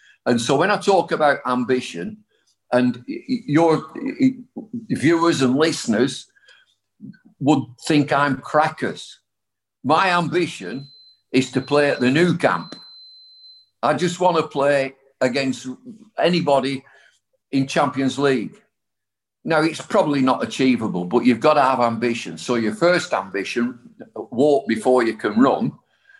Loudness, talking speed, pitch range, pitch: -20 LUFS, 125 wpm, 120-175 Hz, 135 Hz